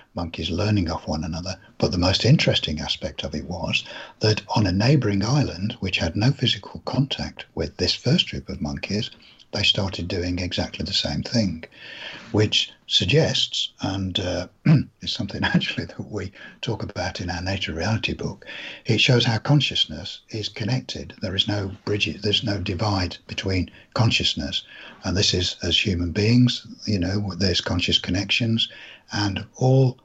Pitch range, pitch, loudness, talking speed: 90-110 Hz, 105 Hz, -23 LUFS, 160 wpm